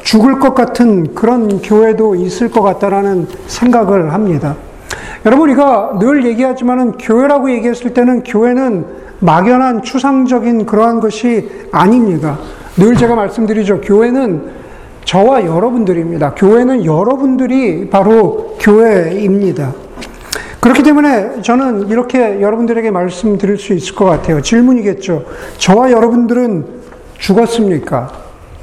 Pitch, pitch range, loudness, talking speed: 220 Hz, 195-245 Hz, -11 LUFS, 300 characters per minute